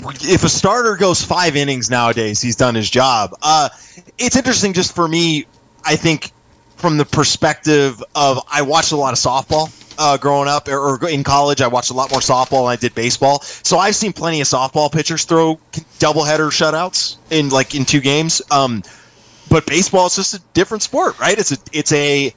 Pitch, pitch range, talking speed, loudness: 145 Hz, 135-165 Hz, 200 wpm, -15 LUFS